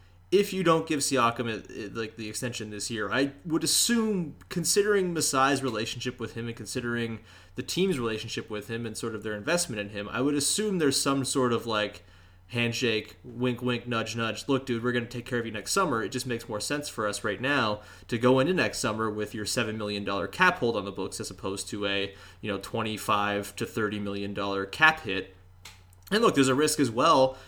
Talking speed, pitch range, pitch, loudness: 225 wpm, 105-130 Hz, 115 Hz, -28 LUFS